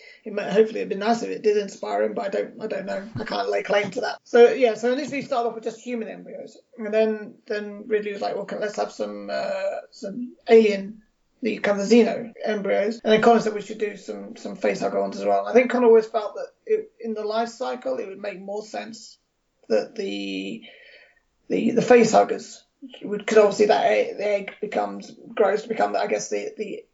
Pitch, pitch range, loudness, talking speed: 220 Hz, 205-245 Hz, -23 LUFS, 225 wpm